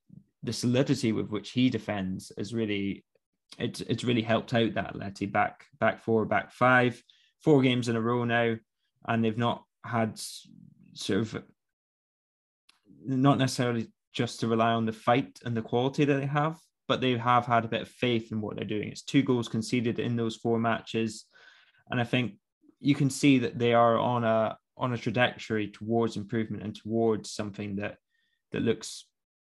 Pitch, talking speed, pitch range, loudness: 115 Hz, 180 wpm, 110-125 Hz, -28 LUFS